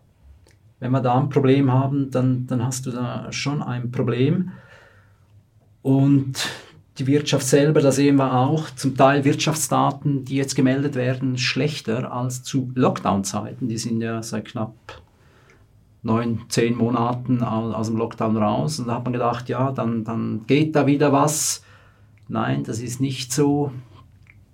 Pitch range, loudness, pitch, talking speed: 110-135 Hz, -21 LUFS, 125 Hz, 150 wpm